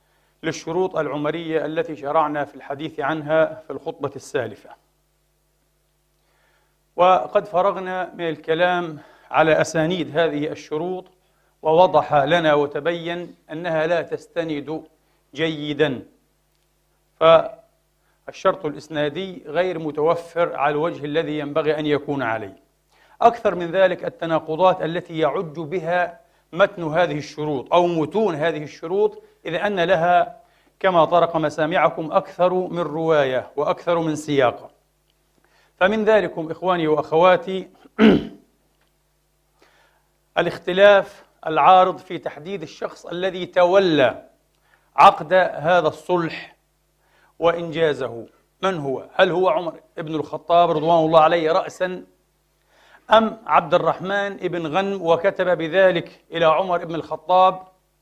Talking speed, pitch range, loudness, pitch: 100 wpm, 155-185 Hz, -20 LUFS, 170 Hz